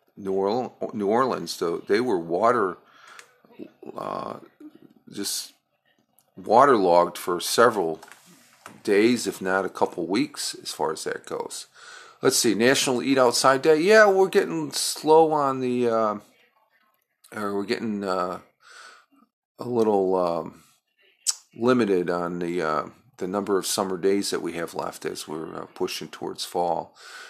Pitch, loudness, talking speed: 130 Hz, -23 LUFS, 135 wpm